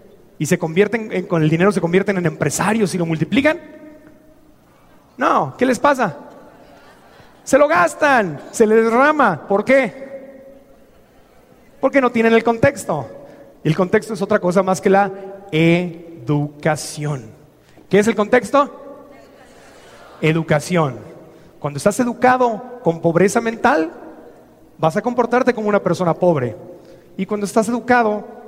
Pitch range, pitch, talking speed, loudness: 170-250 Hz, 205 Hz, 130 wpm, -17 LUFS